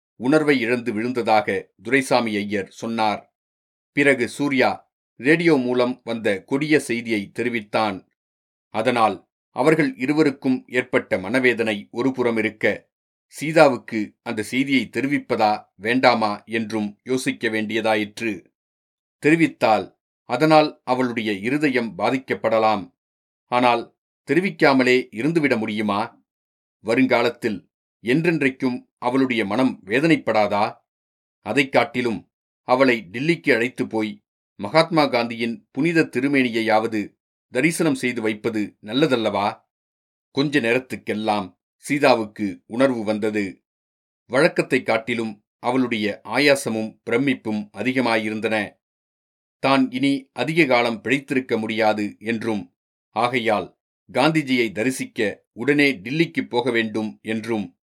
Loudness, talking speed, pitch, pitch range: -21 LUFS, 85 wpm, 120 Hz, 110-135 Hz